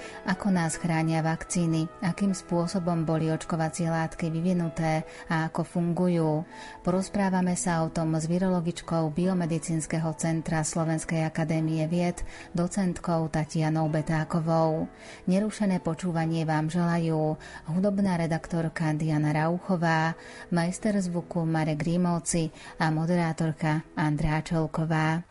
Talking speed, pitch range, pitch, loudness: 100 wpm, 160-175 Hz, 165 Hz, -28 LUFS